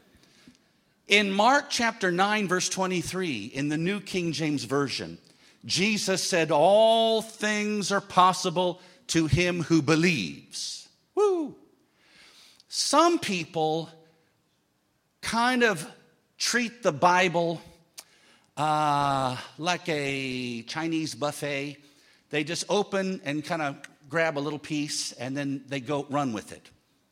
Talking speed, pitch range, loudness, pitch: 115 wpm, 145-195 Hz, -26 LUFS, 165 Hz